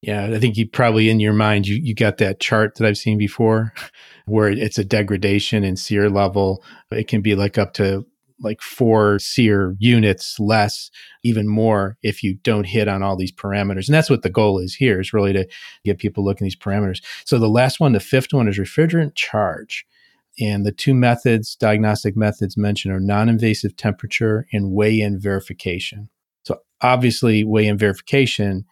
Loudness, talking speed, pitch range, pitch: -18 LUFS, 190 wpm, 100-115 Hz, 105 Hz